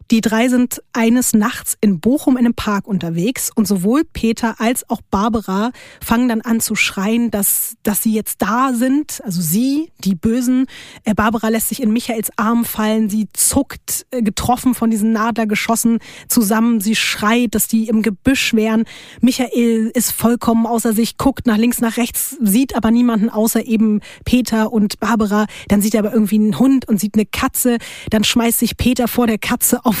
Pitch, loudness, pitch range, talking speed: 230 Hz, -16 LUFS, 220-245 Hz, 180 wpm